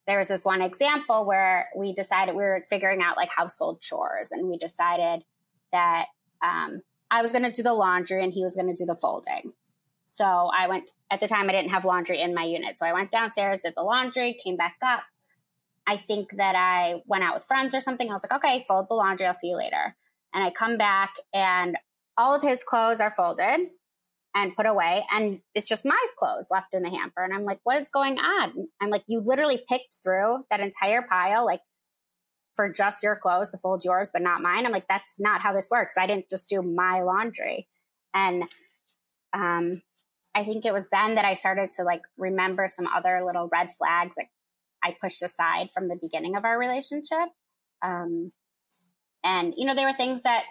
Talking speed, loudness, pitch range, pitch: 215 wpm, -26 LUFS, 180-230 Hz, 195 Hz